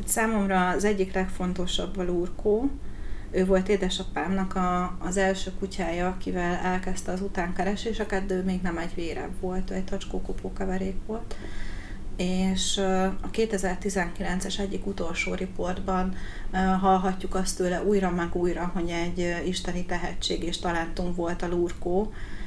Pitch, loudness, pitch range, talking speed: 185 Hz, -28 LUFS, 175-190 Hz, 130 wpm